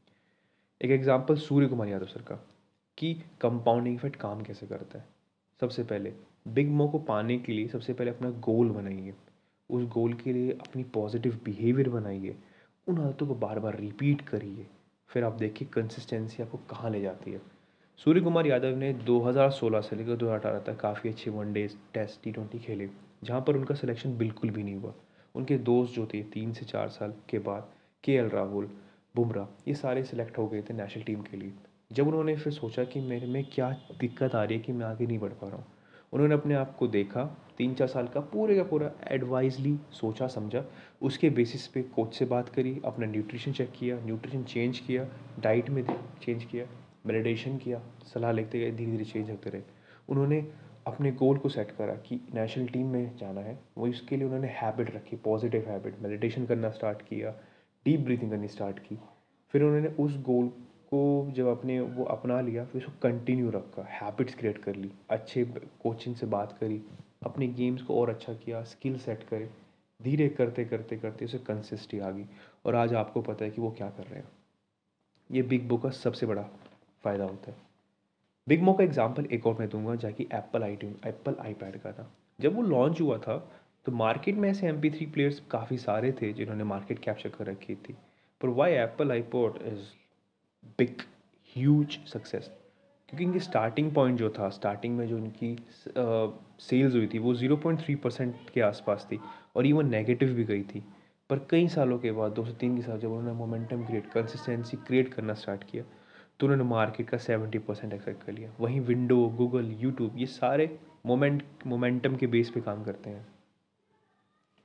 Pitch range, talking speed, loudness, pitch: 110-130 Hz, 195 wpm, -31 LUFS, 120 Hz